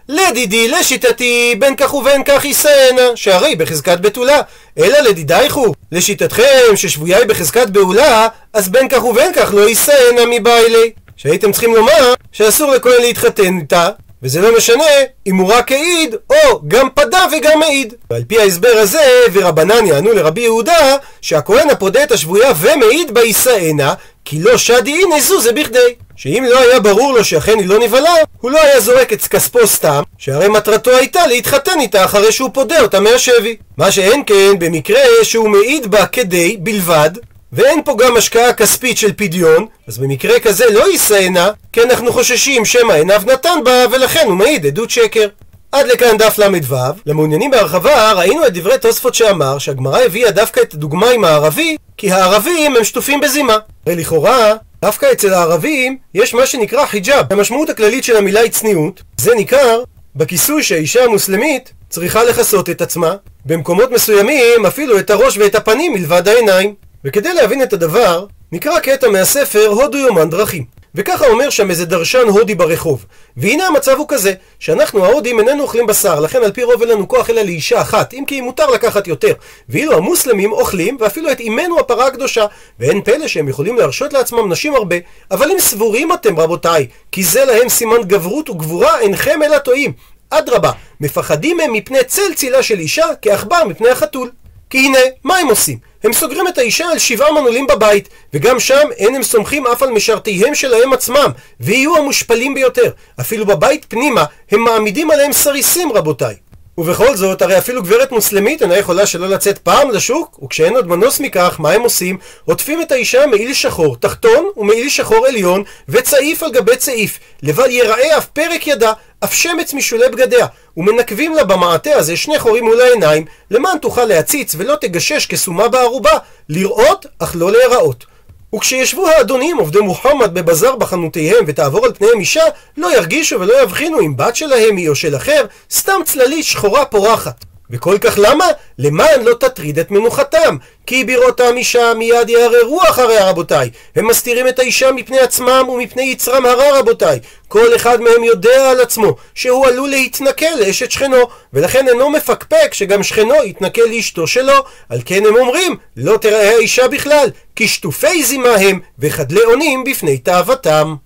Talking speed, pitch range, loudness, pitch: 165 wpm, 210-335 Hz, -11 LUFS, 255 Hz